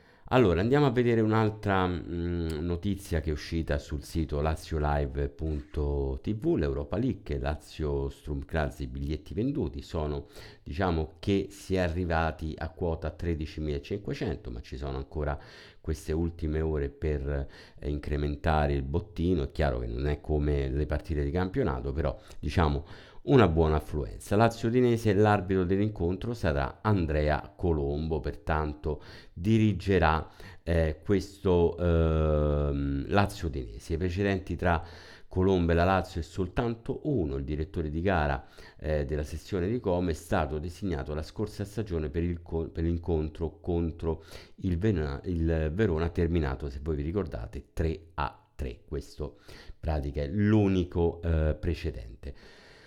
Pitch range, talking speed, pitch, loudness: 75-95 Hz, 135 wpm, 80 Hz, -30 LUFS